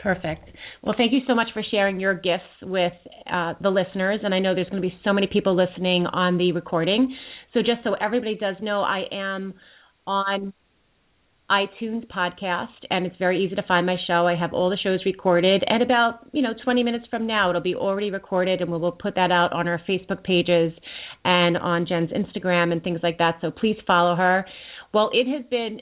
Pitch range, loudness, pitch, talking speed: 180-210 Hz, -23 LUFS, 190 Hz, 210 wpm